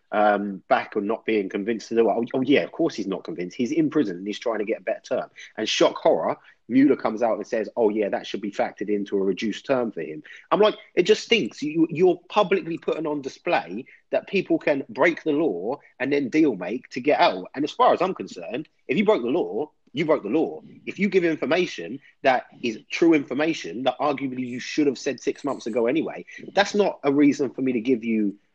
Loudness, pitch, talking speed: -24 LUFS, 145 Hz, 240 wpm